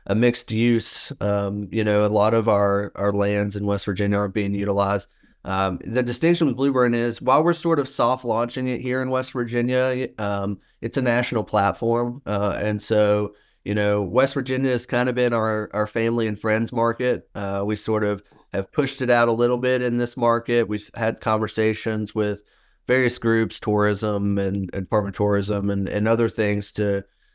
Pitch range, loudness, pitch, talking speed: 100-120 Hz, -22 LUFS, 110 Hz, 190 wpm